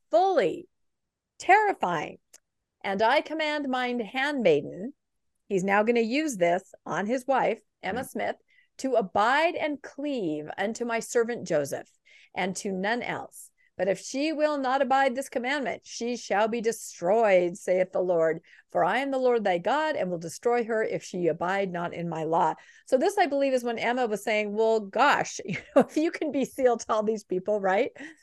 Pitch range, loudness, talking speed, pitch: 195-290 Hz, -27 LUFS, 180 wpm, 240 Hz